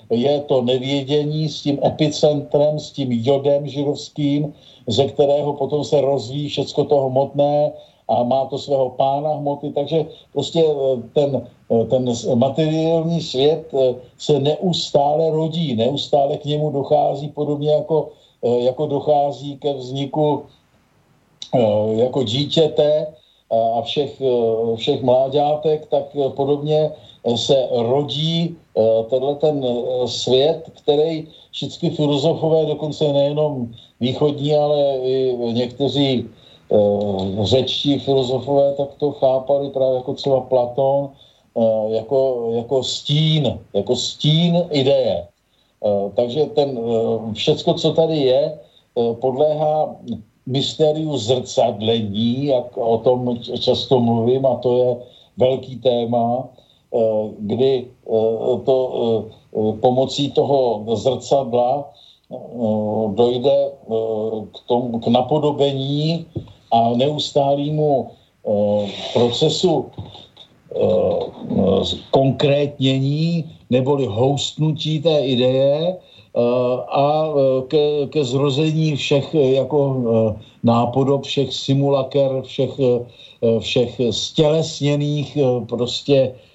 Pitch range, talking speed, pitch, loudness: 125-150 Hz, 90 wpm, 140 Hz, -19 LUFS